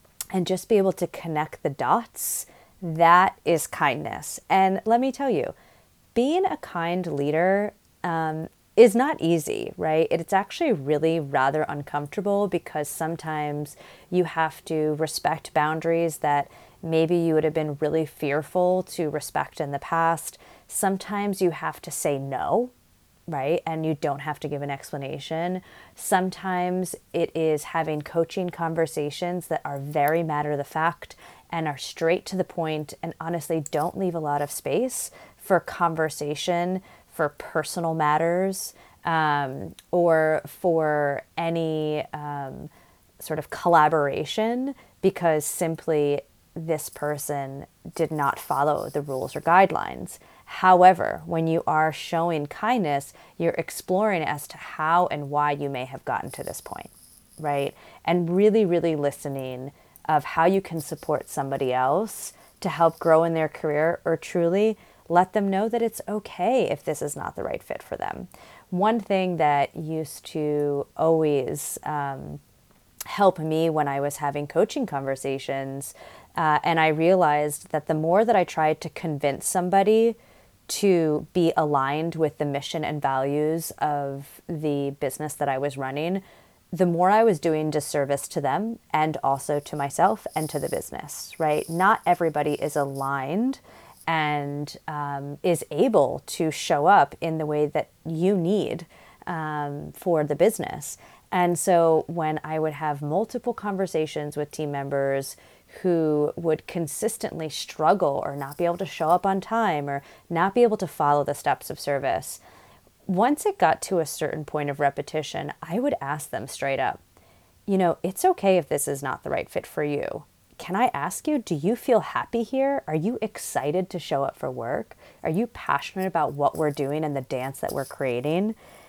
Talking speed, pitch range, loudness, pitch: 160 wpm, 150-180 Hz, -25 LUFS, 160 Hz